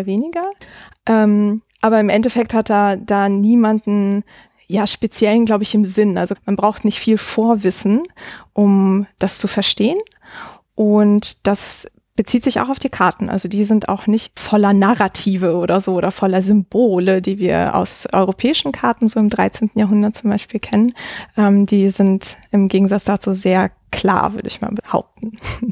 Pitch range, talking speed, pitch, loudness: 195-220 Hz, 160 wpm, 210 Hz, -16 LUFS